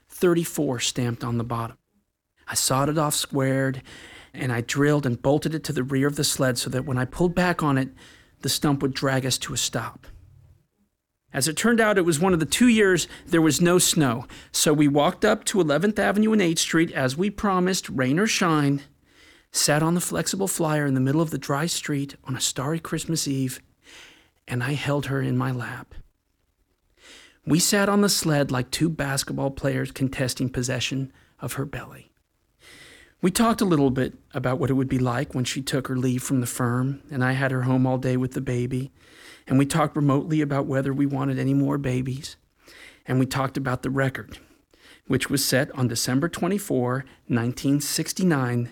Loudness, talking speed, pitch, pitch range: -23 LUFS, 195 wpm, 140 Hz, 130-160 Hz